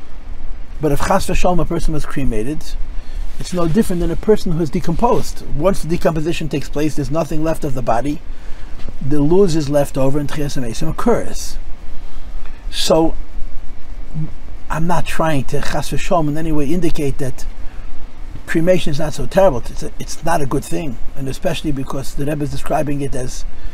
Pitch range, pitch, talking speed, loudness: 135-170 Hz, 150 Hz, 170 wpm, -19 LUFS